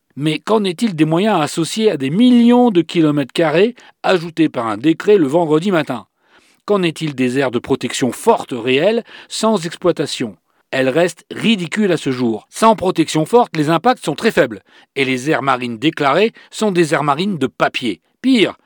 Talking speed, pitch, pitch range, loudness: 175 wpm, 165 Hz, 140-210 Hz, -16 LUFS